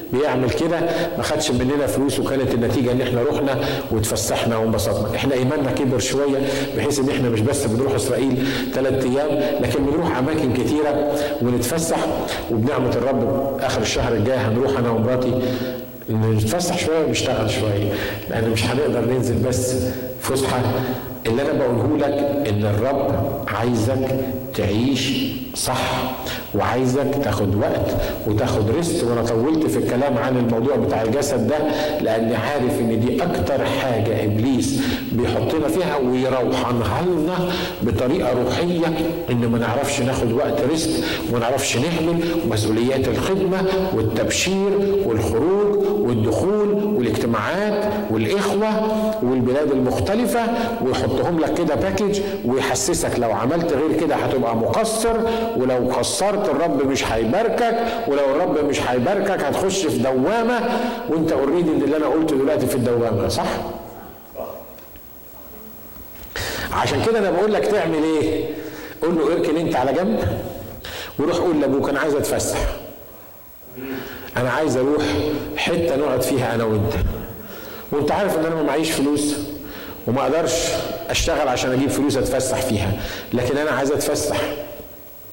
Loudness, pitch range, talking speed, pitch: -20 LUFS, 120-155 Hz, 125 wpm, 130 Hz